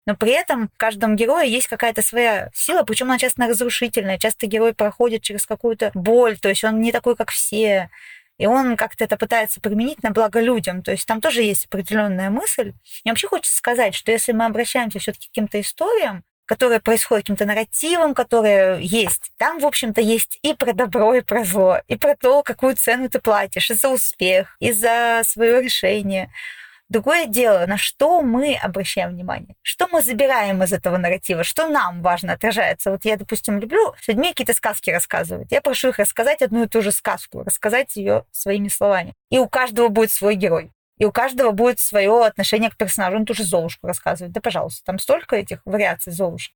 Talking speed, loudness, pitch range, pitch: 195 wpm, -18 LUFS, 205-245 Hz, 225 Hz